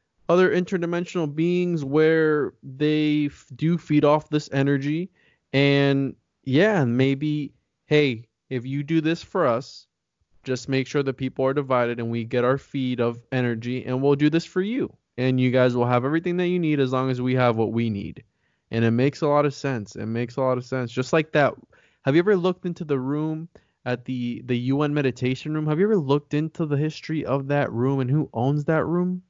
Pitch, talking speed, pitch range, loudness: 140 Hz, 210 wpm, 130-155 Hz, -23 LUFS